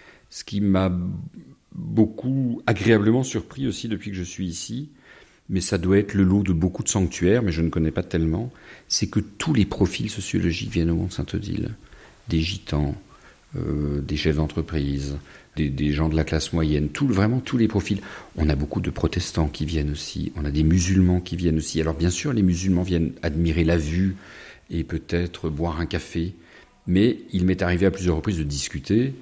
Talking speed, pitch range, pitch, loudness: 195 wpm, 80-100 Hz, 90 Hz, -24 LUFS